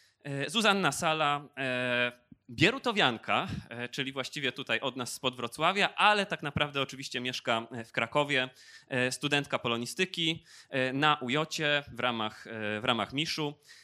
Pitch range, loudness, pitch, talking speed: 125-150 Hz, -30 LUFS, 135 Hz, 115 wpm